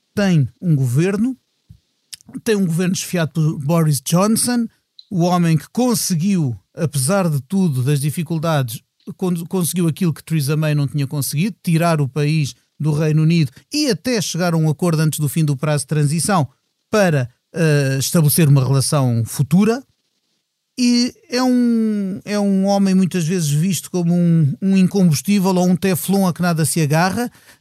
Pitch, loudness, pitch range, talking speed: 170 Hz, -18 LUFS, 150-195 Hz, 160 wpm